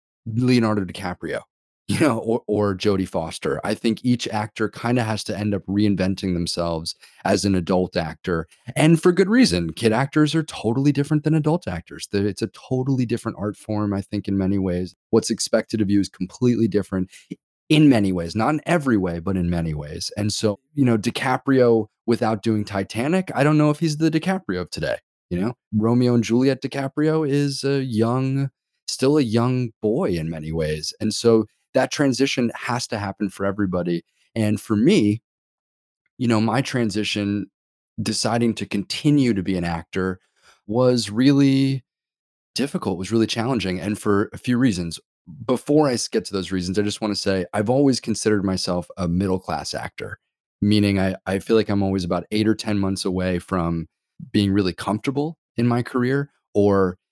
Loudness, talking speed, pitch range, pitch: -22 LUFS, 180 wpm, 95-125 Hz, 110 Hz